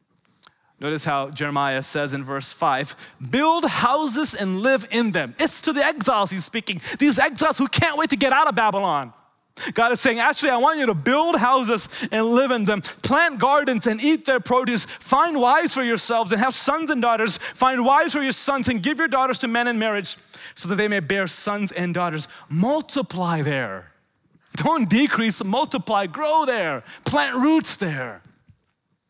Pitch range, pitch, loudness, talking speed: 185-275 Hz, 235 Hz, -21 LUFS, 185 wpm